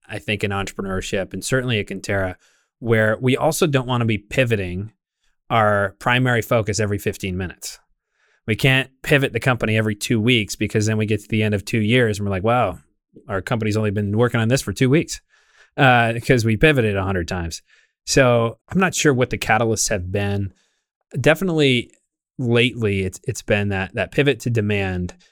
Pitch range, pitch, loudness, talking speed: 100-125 Hz, 110 Hz, -20 LUFS, 190 wpm